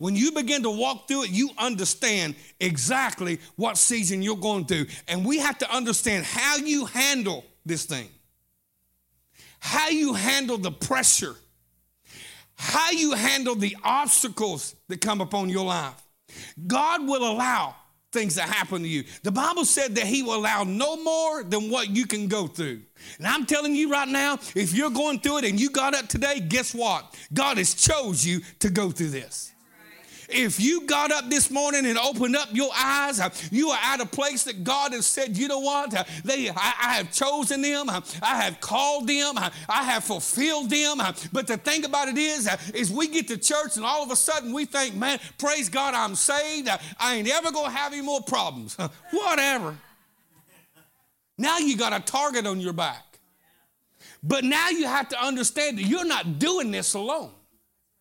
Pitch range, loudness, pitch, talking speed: 190-285 Hz, -24 LUFS, 250 Hz, 180 wpm